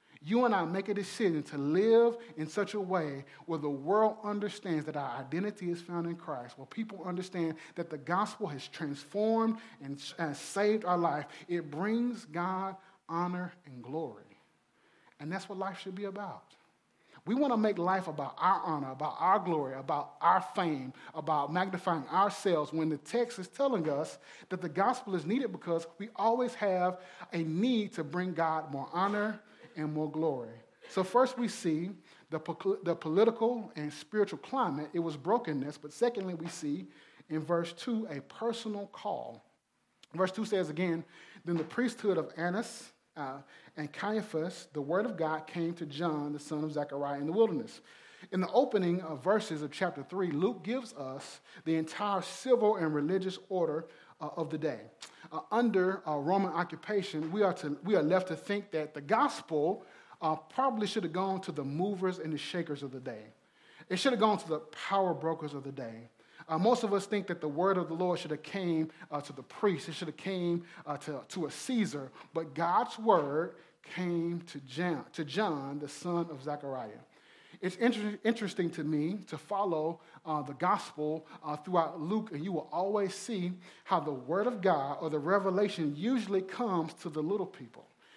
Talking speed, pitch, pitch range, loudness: 185 wpm, 175 Hz, 155-200 Hz, -33 LUFS